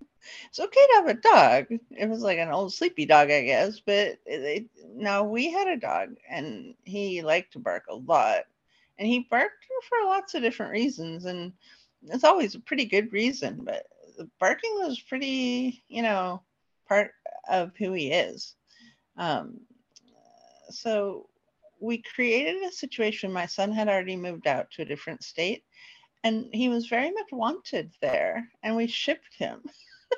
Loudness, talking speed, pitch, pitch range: -26 LUFS, 160 wpm, 235 Hz, 200-315 Hz